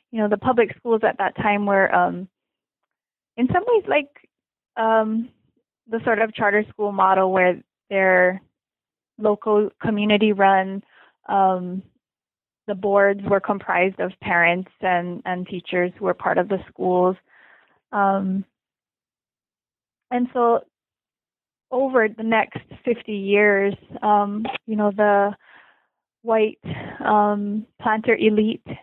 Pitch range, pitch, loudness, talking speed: 190-225 Hz, 210 Hz, -21 LUFS, 120 wpm